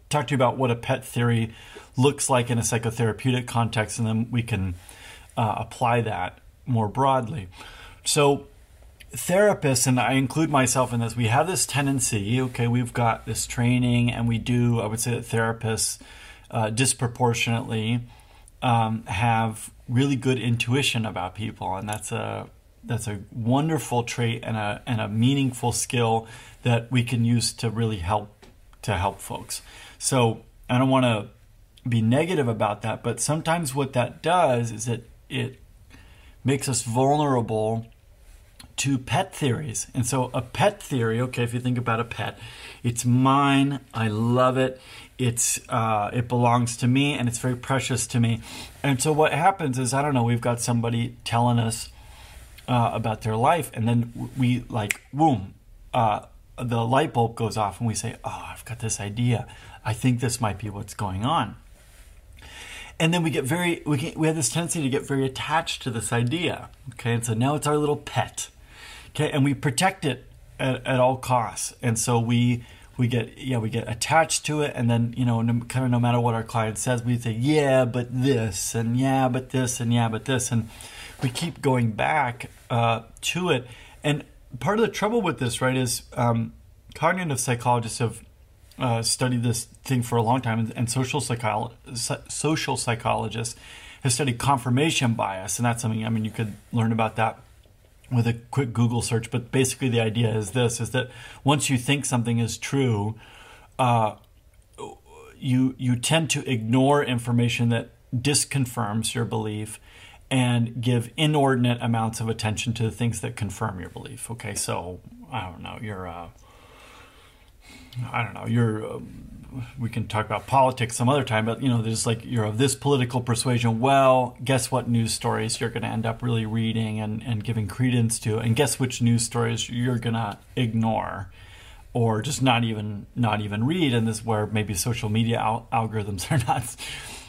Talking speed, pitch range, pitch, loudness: 180 wpm, 110-130 Hz, 120 Hz, -24 LUFS